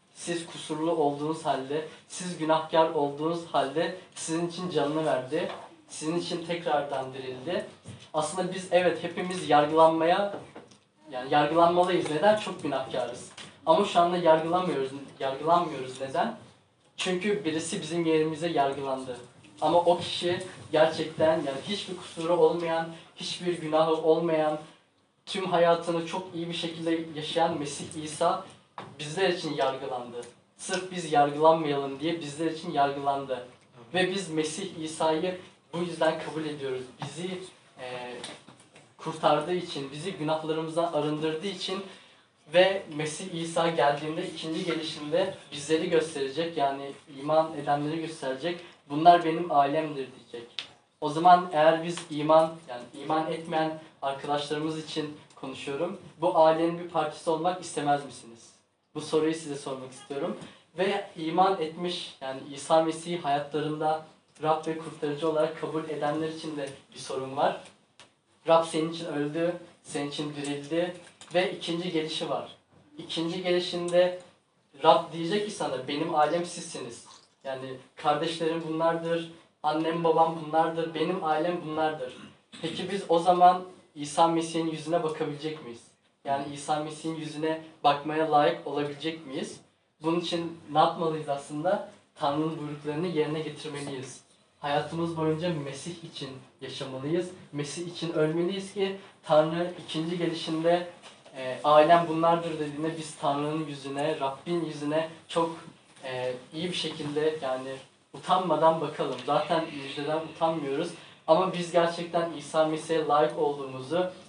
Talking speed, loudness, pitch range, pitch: 125 wpm, -28 LUFS, 150-170 Hz, 160 Hz